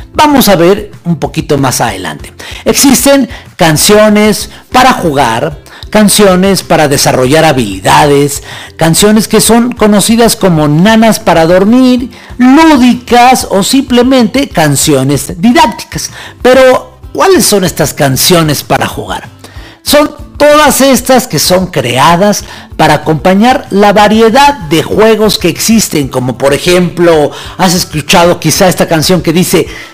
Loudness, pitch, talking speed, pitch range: -6 LUFS, 185 Hz, 120 wpm, 150-230 Hz